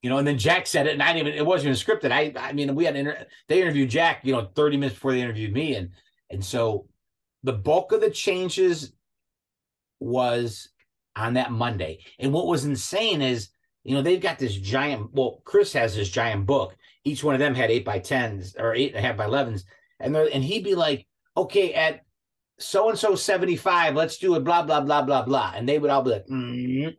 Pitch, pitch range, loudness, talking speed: 135 Hz, 120-160 Hz, -24 LUFS, 230 wpm